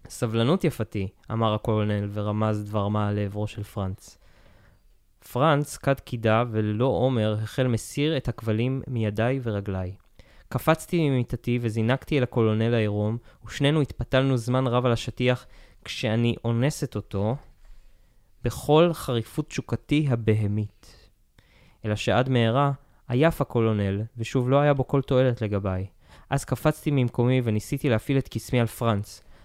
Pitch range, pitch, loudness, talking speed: 105-130 Hz, 115 Hz, -25 LUFS, 125 wpm